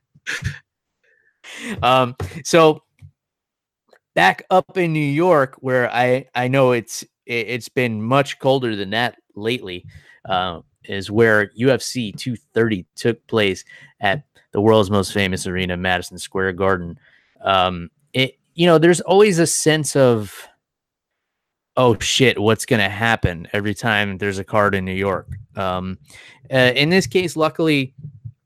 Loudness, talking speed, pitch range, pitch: -18 LUFS, 135 wpm, 100-140 Hz, 120 Hz